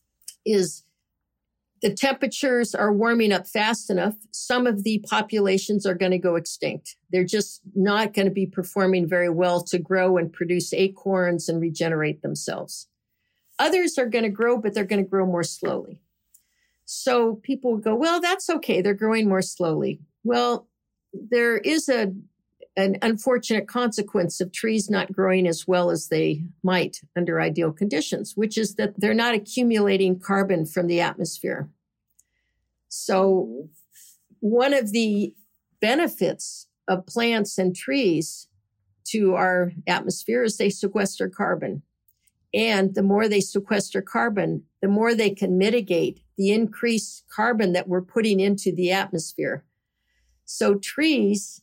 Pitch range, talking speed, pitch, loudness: 180-220 Hz, 145 wpm, 200 Hz, -23 LUFS